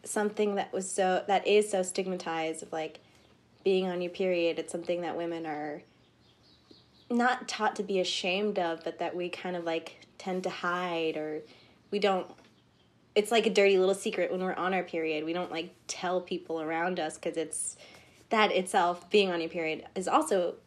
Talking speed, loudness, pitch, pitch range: 190 wpm, -30 LUFS, 180 Hz, 165-190 Hz